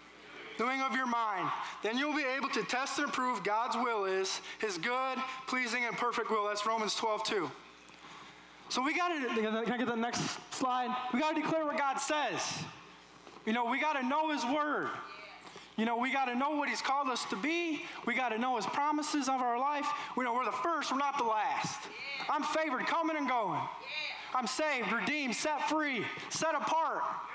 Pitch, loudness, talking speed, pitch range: 260 Hz, -33 LUFS, 200 wpm, 240-300 Hz